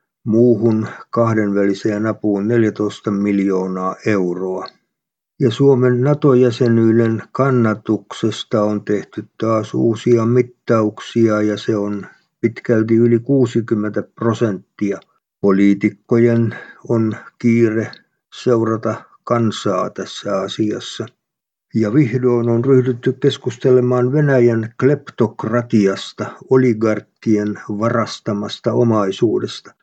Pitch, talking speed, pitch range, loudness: 115 Hz, 80 wpm, 105-120 Hz, -17 LUFS